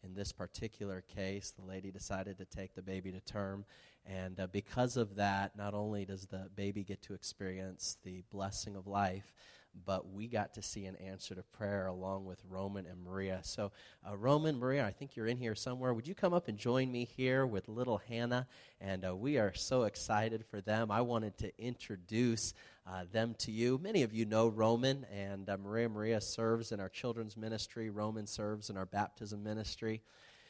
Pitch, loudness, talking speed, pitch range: 105 Hz, -39 LUFS, 200 wpm, 95-115 Hz